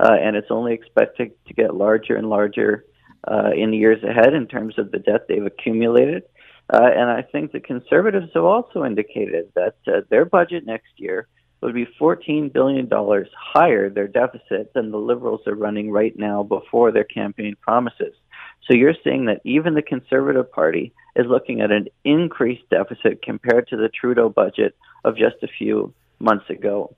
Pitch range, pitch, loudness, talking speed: 110-170 Hz, 125 Hz, -19 LUFS, 185 wpm